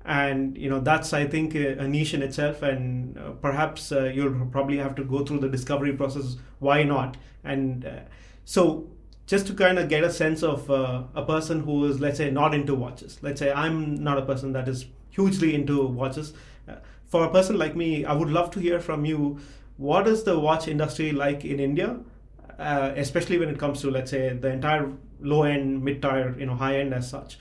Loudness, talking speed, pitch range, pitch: -25 LUFS, 215 wpm, 135-155 Hz, 140 Hz